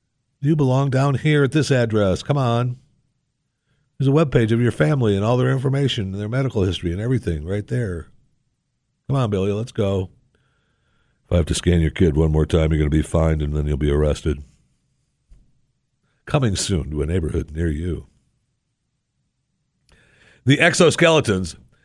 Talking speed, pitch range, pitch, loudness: 170 wpm, 85-135 Hz, 105 Hz, -20 LUFS